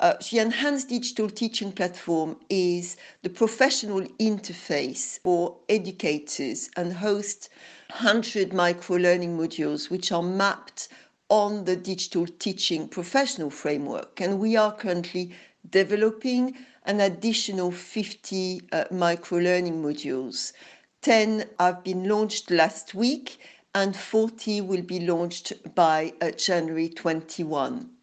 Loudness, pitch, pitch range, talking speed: -26 LUFS, 185 Hz, 175-215 Hz, 115 wpm